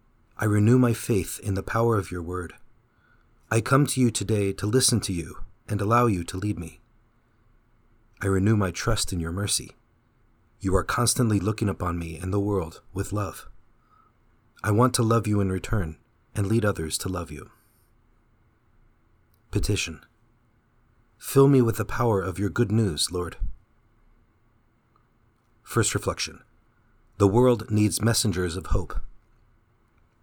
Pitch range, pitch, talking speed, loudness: 95-115 Hz, 110 Hz, 150 wpm, -25 LUFS